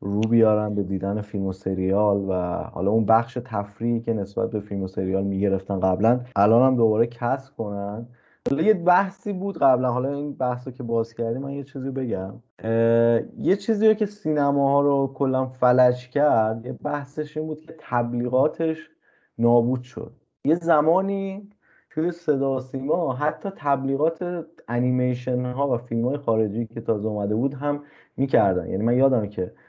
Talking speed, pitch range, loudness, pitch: 160 wpm, 110-145 Hz, -23 LUFS, 125 Hz